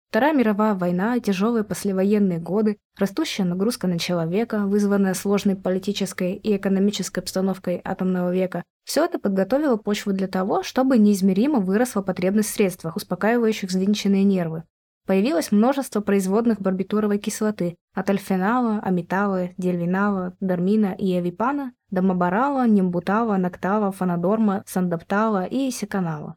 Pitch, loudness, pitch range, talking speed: 200 Hz, -22 LUFS, 185-215 Hz, 120 wpm